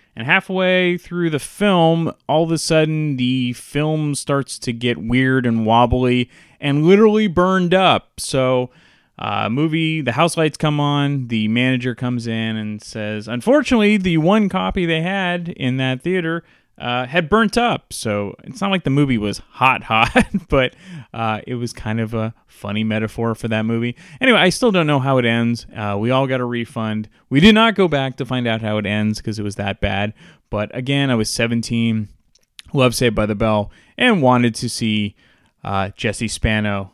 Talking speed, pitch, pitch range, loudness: 190 wpm, 125 Hz, 110-165 Hz, -18 LUFS